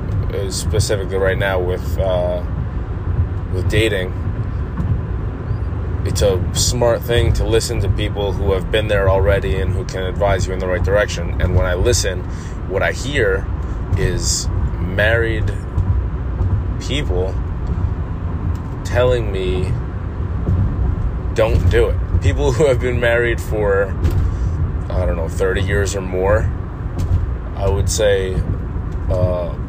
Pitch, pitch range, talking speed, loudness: 95 Hz, 90-100 Hz, 125 wpm, -19 LUFS